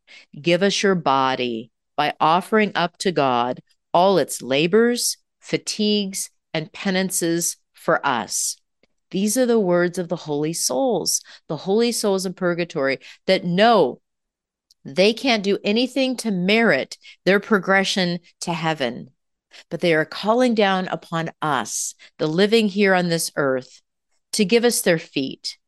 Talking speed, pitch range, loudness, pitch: 140 wpm, 165-210 Hz, -20 LUFS, 185 Hz